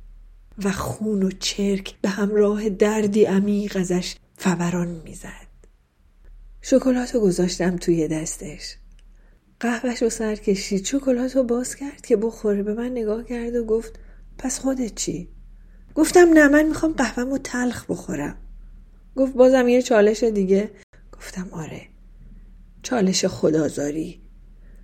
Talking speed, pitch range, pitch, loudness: 125 wpm, 175-245 Hz, 205 Hz, -21 LUFS